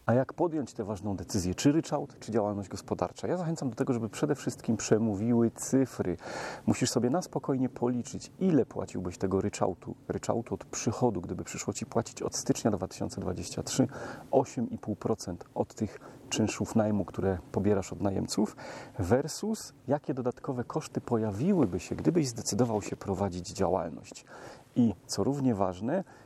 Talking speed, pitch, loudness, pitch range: 145 wpm, 115 Hz, -31 LUFS, 100-135 Hz